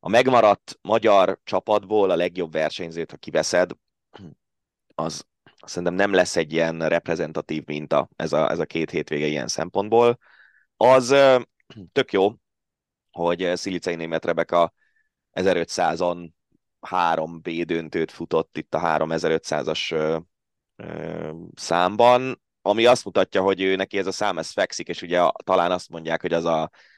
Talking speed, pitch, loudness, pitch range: 135 wpm, 90 Hz, -22 LUFS, 80-100 Hz